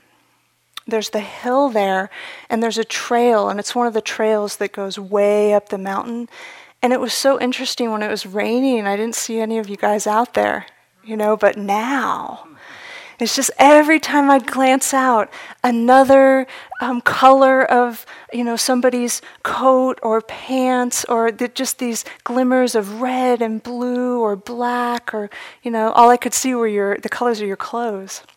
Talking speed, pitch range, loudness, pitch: 180 wpm, 215-255 Hz, -17 LUFS, 240 Hz